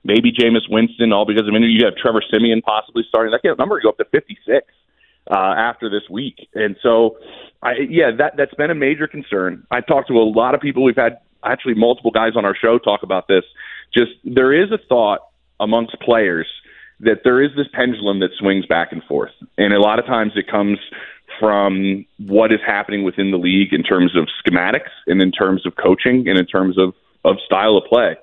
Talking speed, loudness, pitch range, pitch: 215 wpm, -16 LUFS, 100-125 Hz, 110 Hz